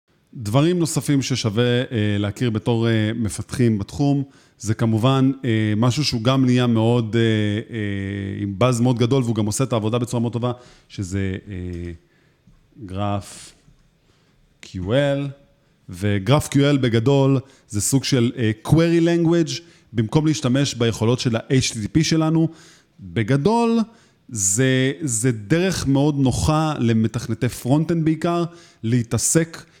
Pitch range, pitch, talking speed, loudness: 110-145 Hz, 125 Hz, 120 wpm, -20 LUFS